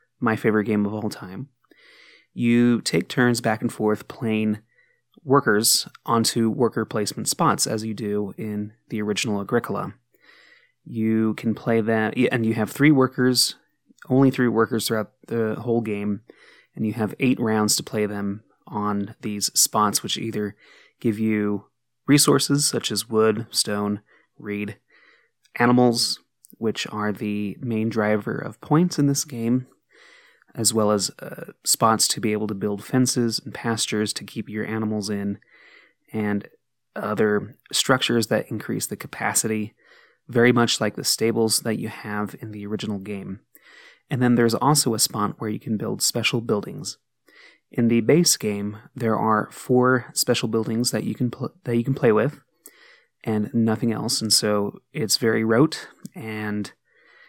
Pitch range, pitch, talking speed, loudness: 105-120 Hz, 110 Hz, 155 wpm, -22 LUFS